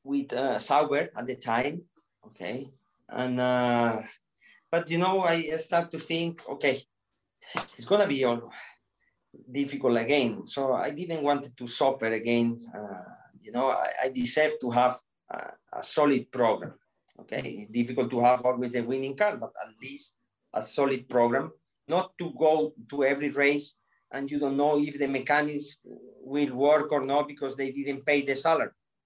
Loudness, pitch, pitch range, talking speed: -28 LUFS, 140 Hz, 125-155 Hz, 165 wpm